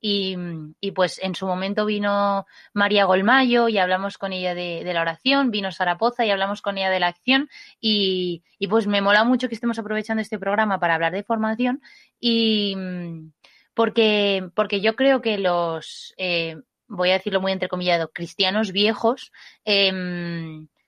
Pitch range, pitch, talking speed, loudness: 180-220 Hz, 200 Hz, 165 wpm, -22 LUFS